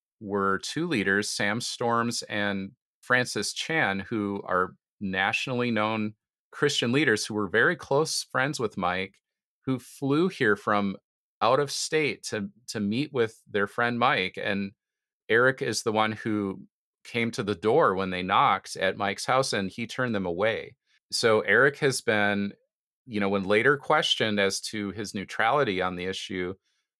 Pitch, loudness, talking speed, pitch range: 105 Hz, -26 LUFS, 160 wpm, 100-120 Hz